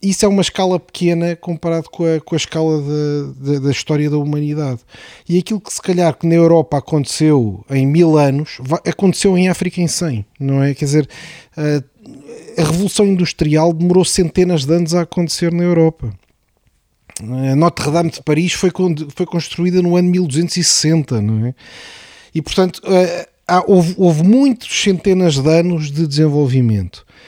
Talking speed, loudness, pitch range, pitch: 155 wpm, -15 LUFS, 145-180 Hz, 165 Hz